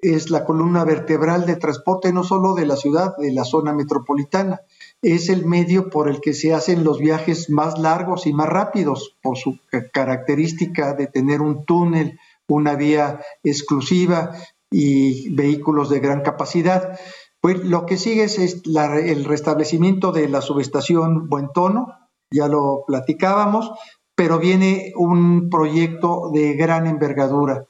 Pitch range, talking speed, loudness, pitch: 145-180 Hz, 145 wpm, -19 LUFS, 160 Hz